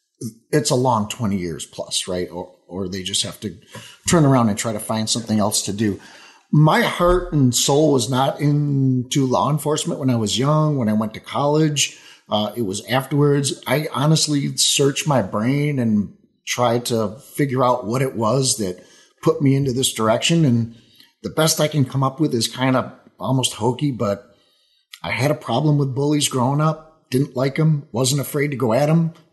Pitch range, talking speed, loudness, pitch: 110-145 Hz, 195 wpm, -19 LUFS, 130 Hz